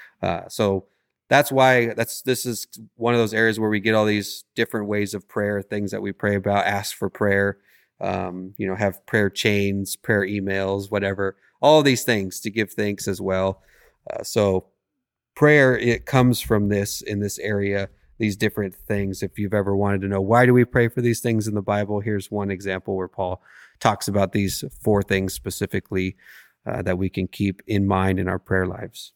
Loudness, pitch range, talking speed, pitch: -22 LUFS, 100-110 Hz, 200 wpm, 100 Hz